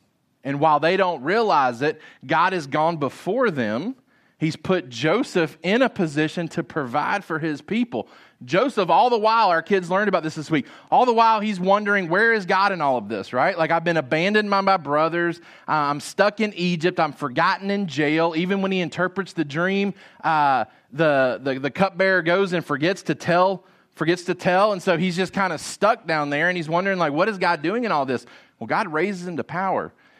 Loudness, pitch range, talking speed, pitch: -21 LUFS, 160-195 Hz, 210 wpm, 175 Hz